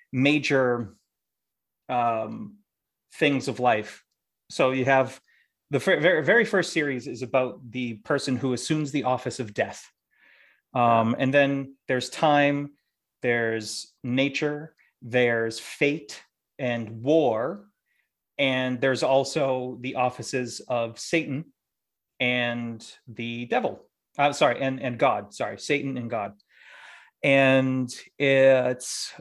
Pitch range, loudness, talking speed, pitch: 120-145 Hz, -25 LUFS, 115 wpm, 130 Hz